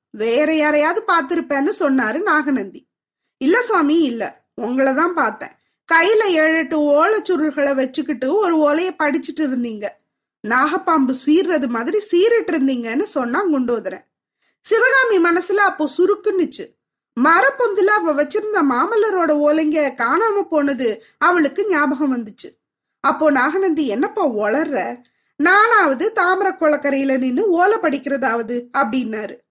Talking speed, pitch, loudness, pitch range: 105 wpm, 310 Hz, -17 LUFS, 275-370 Hz